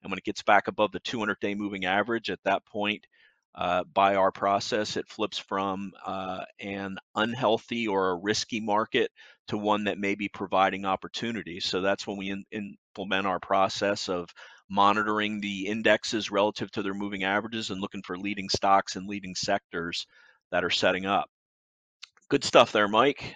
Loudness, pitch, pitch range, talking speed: -28 LUFS, 100 Hz, 95-105 Hz, 175 wpm